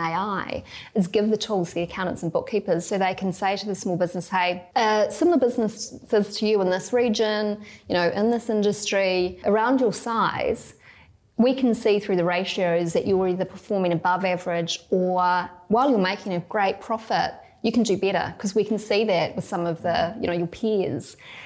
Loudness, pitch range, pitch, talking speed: -23 LUFS, 180-215 Hz, 195 Hz, 200 wpm